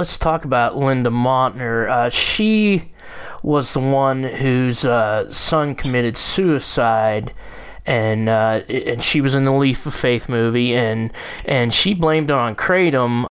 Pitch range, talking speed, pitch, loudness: 120-150 Hz, 150 wpm, 130 Hz, -18 LUFS